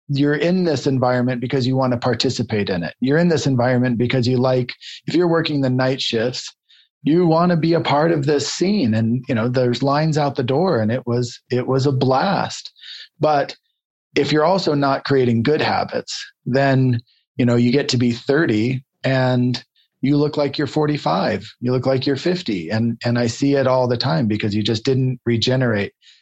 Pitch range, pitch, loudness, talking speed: 125-145 Hz, 130 Hz, -19 LUFS, 200 wpm